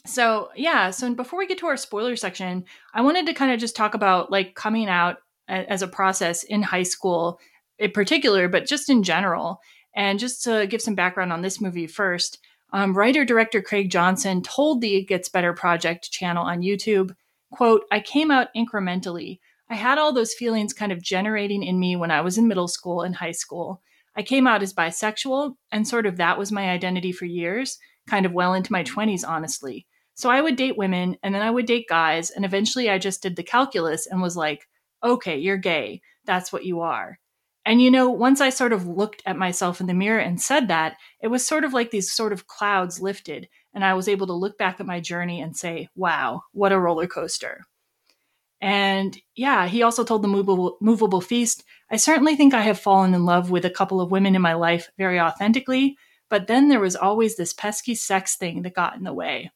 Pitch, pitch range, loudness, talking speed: 195 Hz, 180-230 Hz, -22 LUFS, 215 wpm